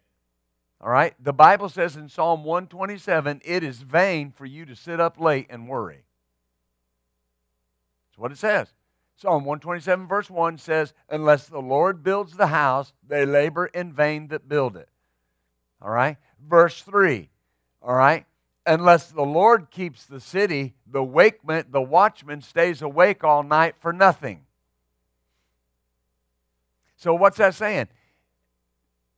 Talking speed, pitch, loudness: 140 wpm, 145 Hz, -21 LUFS